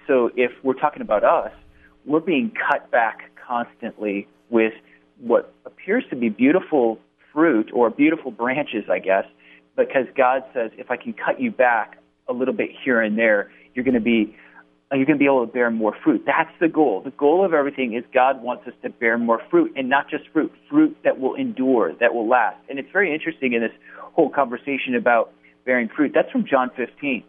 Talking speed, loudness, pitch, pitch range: 200 wpm, -21 LUFS, 125 Hz, 115-150 Hz